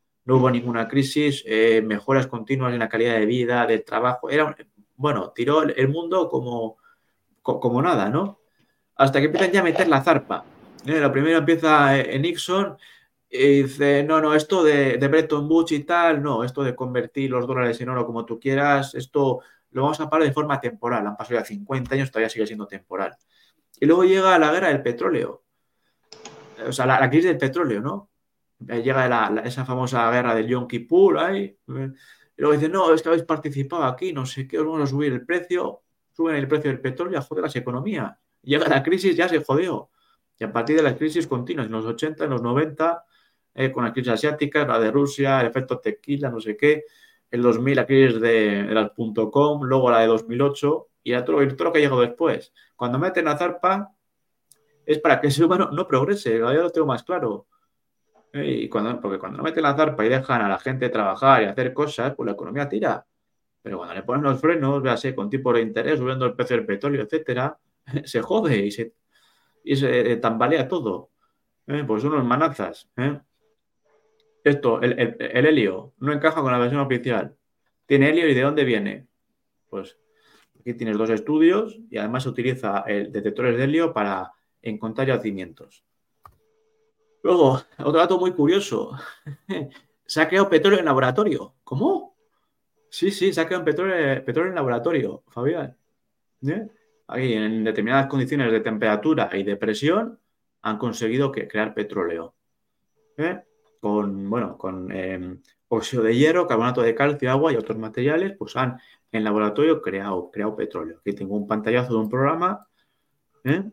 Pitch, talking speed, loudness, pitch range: 135 Hz, 185 wpm, -22 LUFS, 120-160 Hz